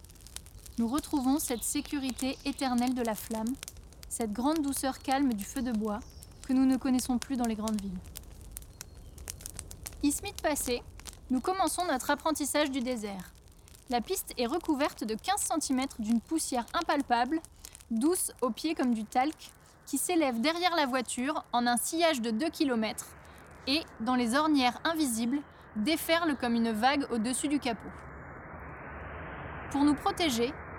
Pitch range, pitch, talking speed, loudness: 230-300 Hz, 260 Hz, 145 wpm, -31 LUFS